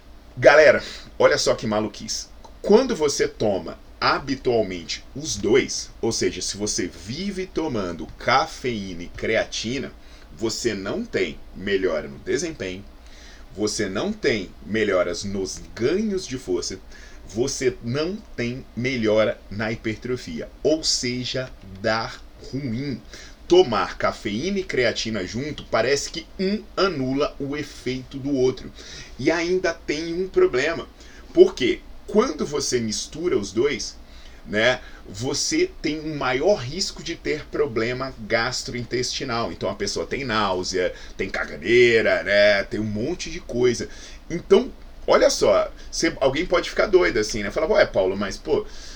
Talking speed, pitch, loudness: 130 wpm, 130 Hz, -23 LUFS